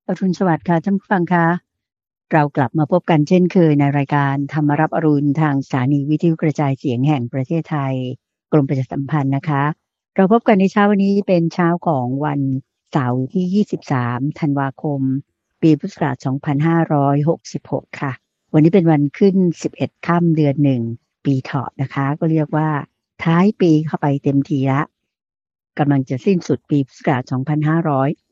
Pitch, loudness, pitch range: 150 Hz, -18 LUFS, 140-170 Hz